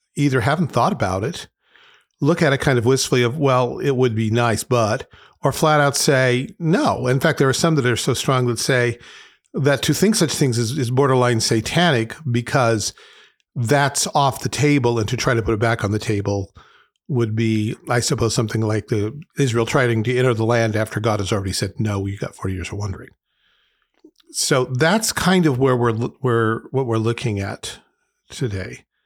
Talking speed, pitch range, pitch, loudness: 200 wpm, 115-140 Hz, 125 Hz, -19 LUFS